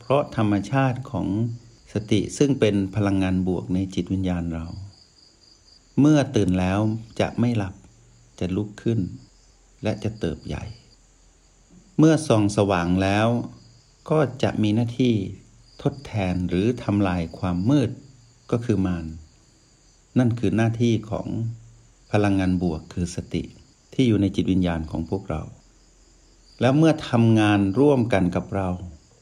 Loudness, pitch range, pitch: -23 LUFS, 95-120 Hz, 105 Hz